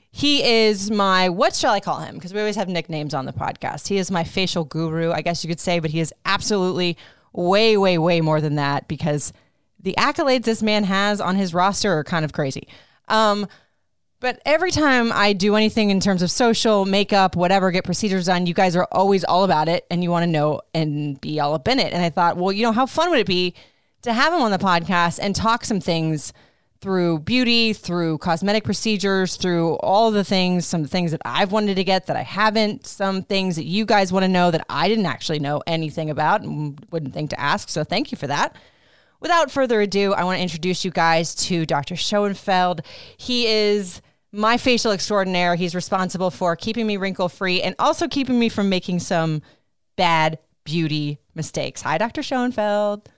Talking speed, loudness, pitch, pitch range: 210 wpm, -20 LUFS, 185 Hz, 165-210 Hz